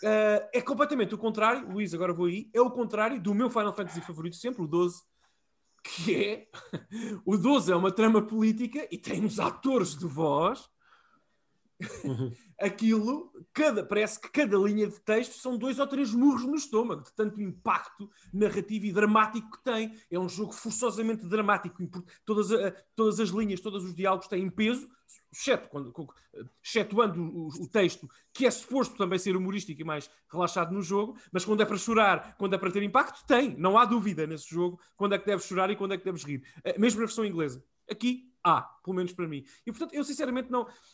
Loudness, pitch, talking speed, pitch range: -29 LUFS, 210 Hz, 195 wpm, 185-235 Hz